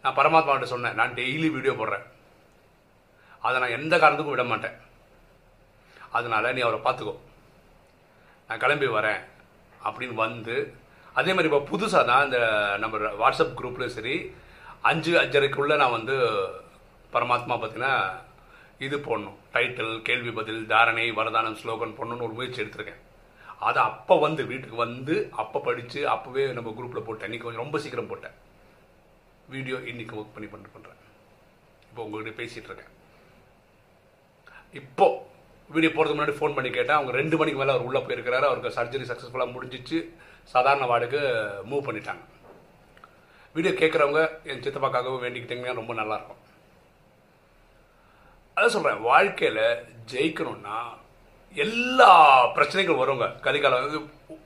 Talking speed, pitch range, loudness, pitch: 120 wpm, 120-160 Hz, -25 LUFS, 135 Hz